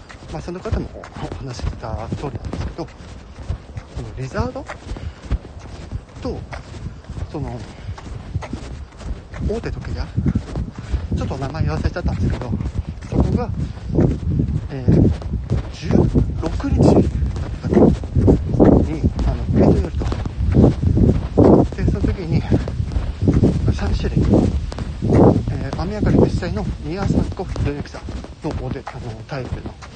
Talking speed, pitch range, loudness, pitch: 185 characters per minute, 85-110 Hz, -20 LUFS, 100 Hz